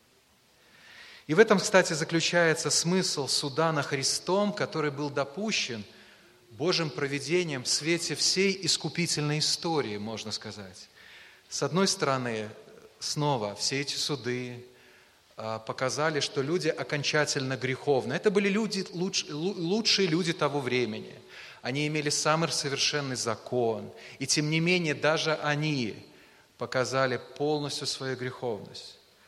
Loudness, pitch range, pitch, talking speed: -28 LUFS, 130-165 Hz, 150 Hz, 115 wpm